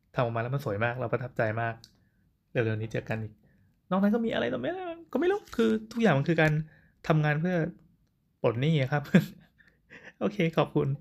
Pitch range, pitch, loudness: 115-185 Hz, 150 Hz, -29 LUFS